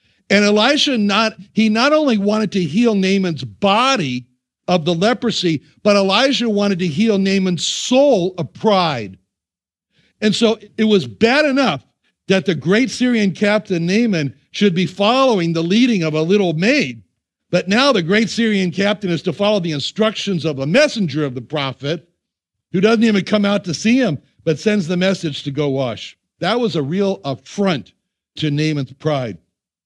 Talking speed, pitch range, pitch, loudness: 170 wpm, 155-215 Hz, 195 Hz, -17 LUFS